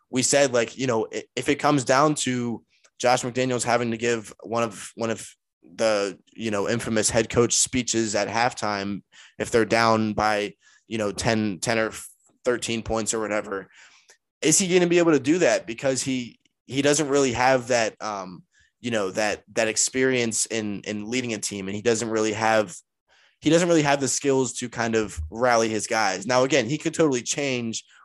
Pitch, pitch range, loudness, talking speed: 115 Hz, 110-130 Hz, -23 LUFS, 195 wpm